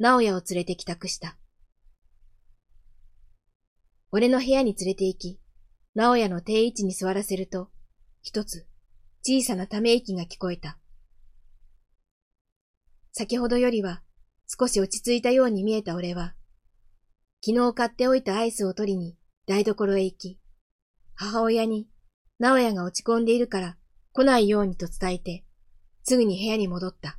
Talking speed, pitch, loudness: 270 characters per minute, 185 Hz, -25 LUFS